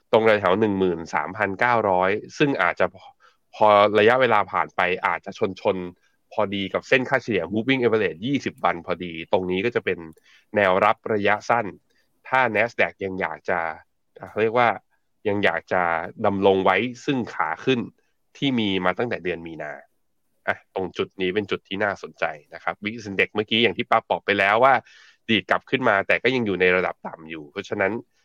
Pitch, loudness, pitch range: 100 Hz, -22 LUFS, 90-110 Hz